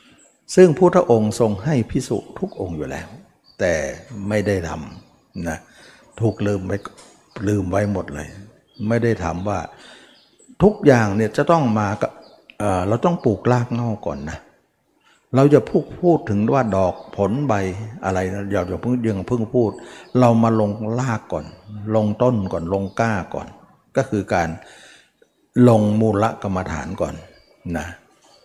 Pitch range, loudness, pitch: 100-120 Hz, -20 LUFS, 110 Hz